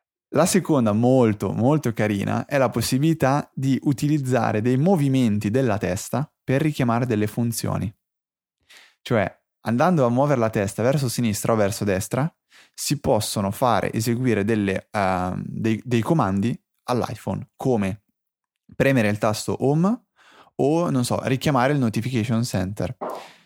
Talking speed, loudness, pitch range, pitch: 130 wpm, -22 LUFS, 105-135 Hz, 120 Hz